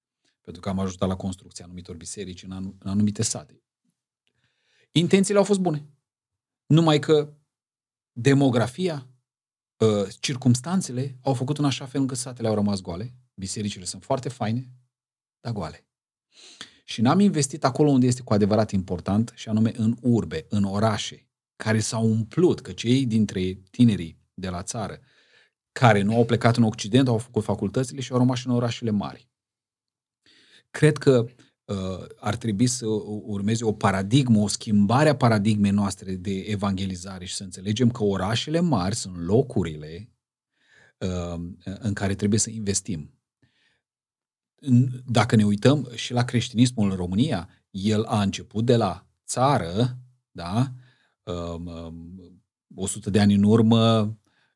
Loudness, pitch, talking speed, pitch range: -24 LUFS, 110 Hz, 140 wpm, 100-125 Hz